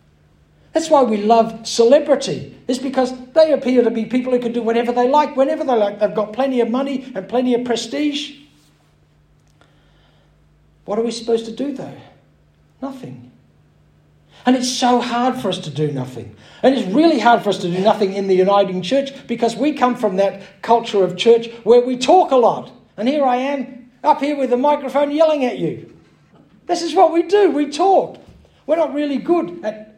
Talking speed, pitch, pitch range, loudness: 195 wpm, 245 Hz, 215-280 Hz, -17 LUFS